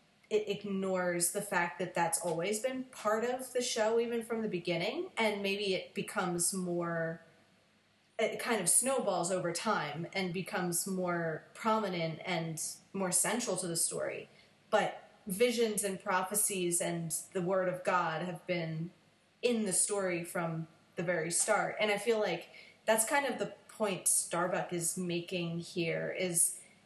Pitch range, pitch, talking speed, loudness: 175-210 Hz, 185 Hz, 155 wpm, -33 LUFS